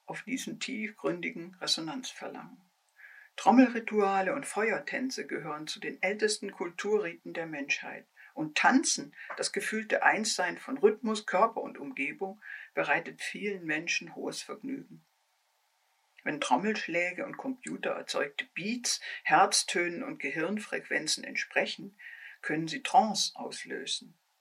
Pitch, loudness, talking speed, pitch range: 220 Hz, -31 LUFS, 105 wpm, 190-270 Hz